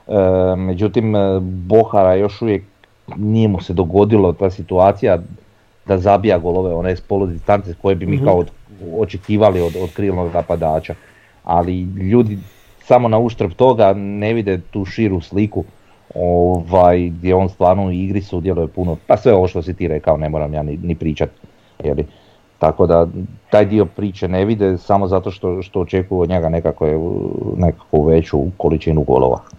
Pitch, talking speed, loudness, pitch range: 95 Hz, 160 wpm, -16 LUFS, 90-105 Hz